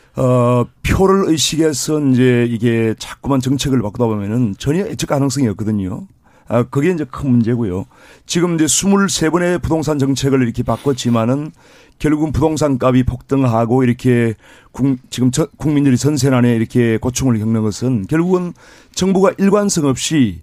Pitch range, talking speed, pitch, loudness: 120-155 Hz, 330 characters per minute, 130 Hz, -15 LUFS